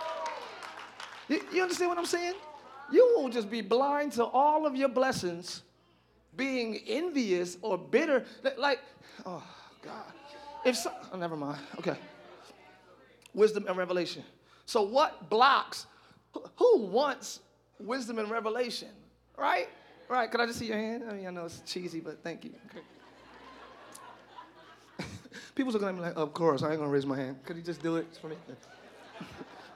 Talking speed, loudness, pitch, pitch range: 160 wpm, -31 LUFS, 235 Hz, 175-280 Hz